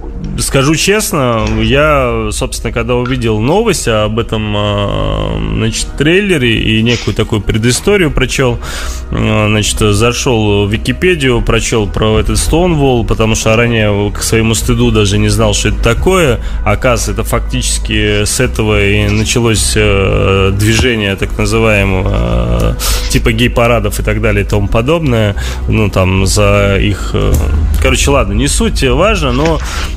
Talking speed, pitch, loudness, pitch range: 130 wpm, 110 Hz, -11 LUFS, 100-120 Hz